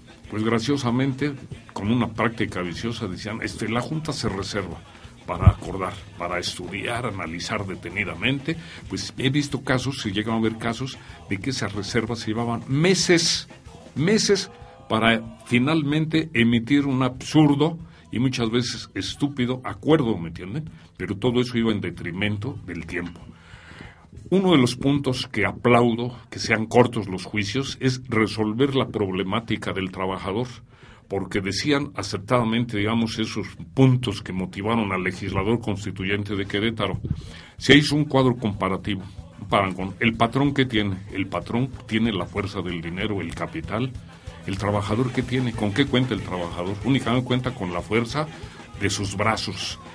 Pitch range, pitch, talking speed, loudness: 100-125 Hz, 110 Hz, 145 wpm, -24 LUFS